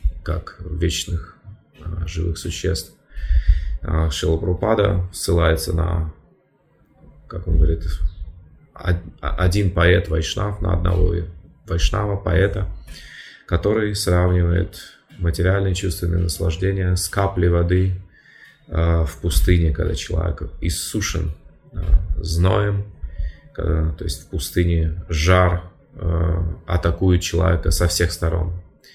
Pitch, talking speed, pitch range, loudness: 85 Hz, 85 wpm, 80-90 Hz, -21 LUFS